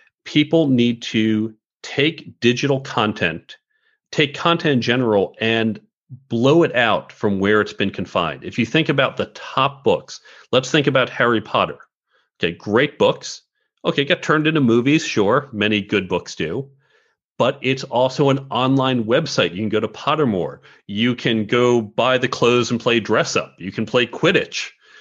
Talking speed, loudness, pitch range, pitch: 165 wpm, -19 LUFS, 110-150 Hz, 125 Hz